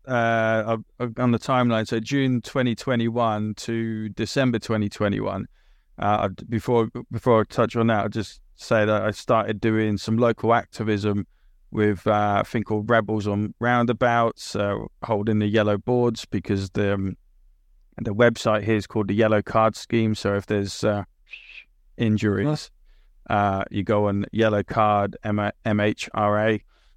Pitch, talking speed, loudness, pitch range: 110 Hz, 145 wpm, -23 LUFS, 105-115 Hz